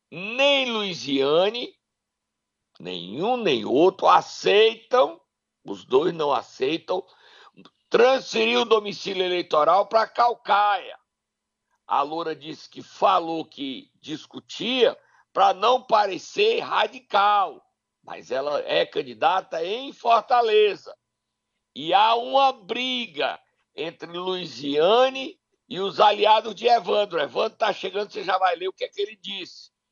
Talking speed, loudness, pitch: 115 wpm, -22 LUFS, 230 Hz